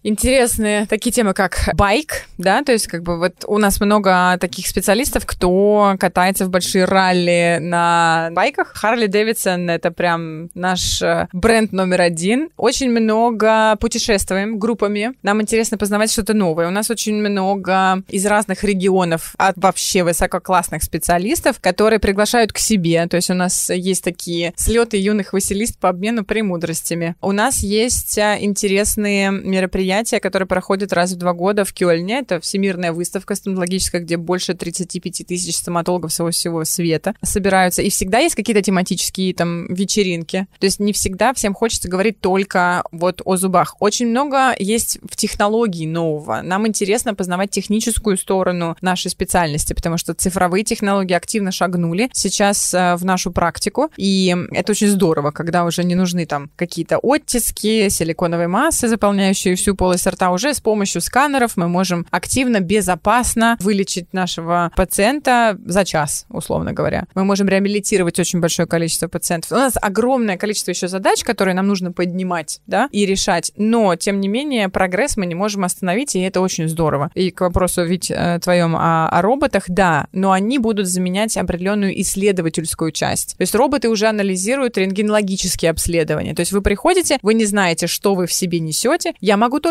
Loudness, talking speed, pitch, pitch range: -17 LUFS, 160 wpm, 190 Hz, 175-210 Hz